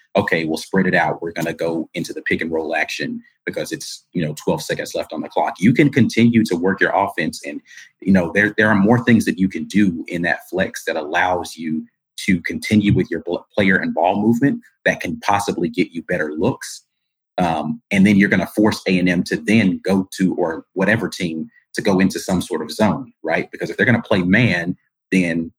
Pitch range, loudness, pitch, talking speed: 85-110 Hz, -19 LUFS, 95 Hz, 220 wpm